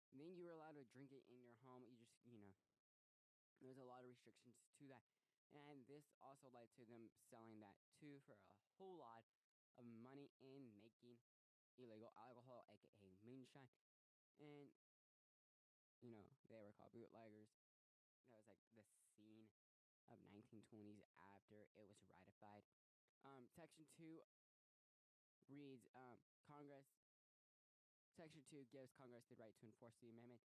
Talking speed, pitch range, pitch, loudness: 140 wpm, 110-135 Hz, 120 Hz, -67 LUFS